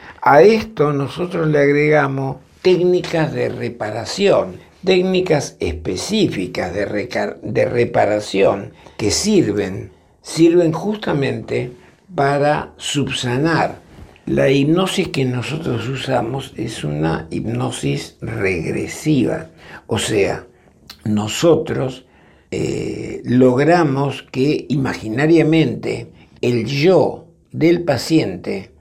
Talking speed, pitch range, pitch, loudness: 85 wpm, 120-165 Hz, 140 Hz, -17 LUFS